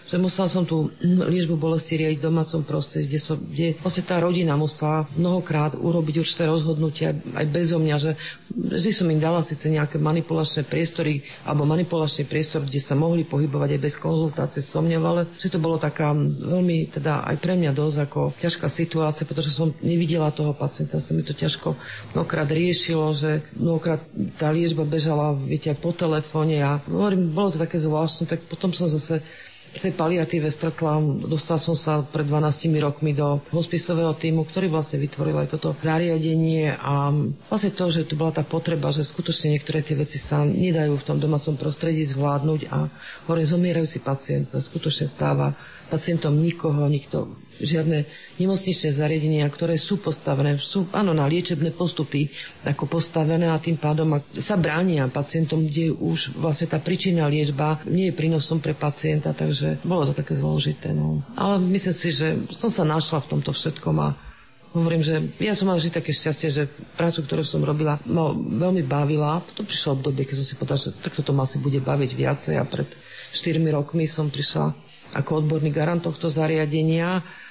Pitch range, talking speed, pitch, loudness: 150-165 Hz, 175 wpm, 155 Hz, -23 LUFS